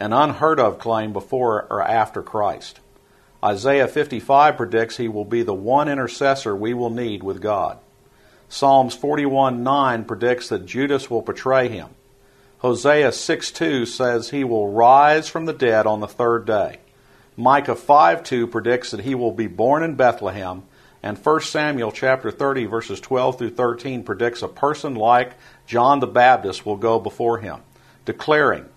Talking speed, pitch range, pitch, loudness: 155 wpm, 115-135 Hz, 125 Hz, -19 LUFS